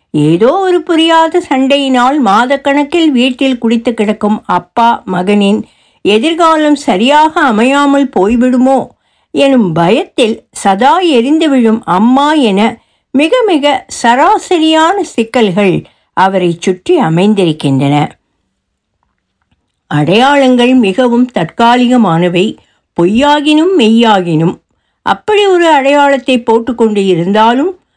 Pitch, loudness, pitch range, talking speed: 250 Hz, -9 LUFS, 205-290 Hz, 80 wpm